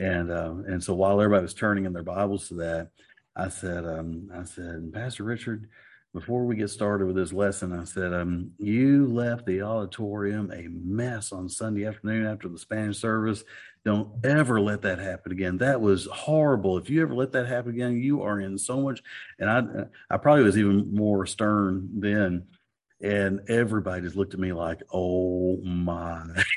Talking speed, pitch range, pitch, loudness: 185 wpm, 90-110 Hz, 100 Hz, -27 LUFS